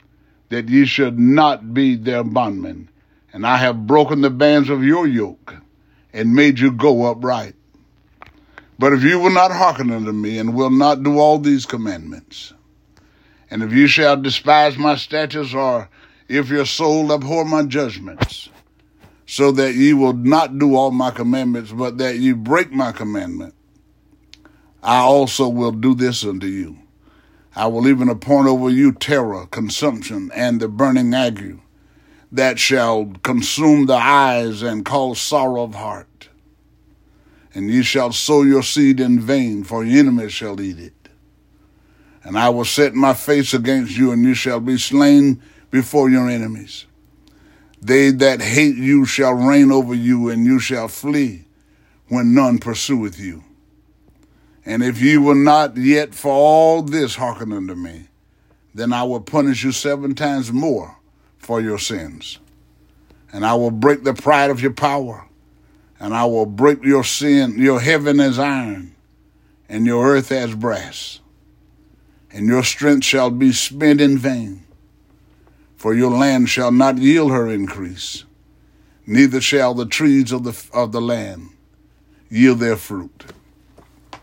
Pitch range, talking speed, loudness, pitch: 115-140 Hz, 155 wpm, -16 LUFS, 130 Hz